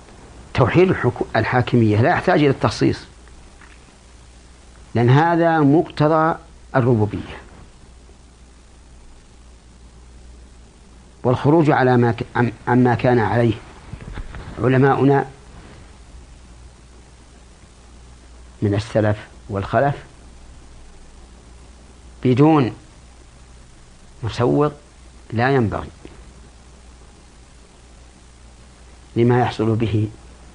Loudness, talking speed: -18 LUFS, 55 wpm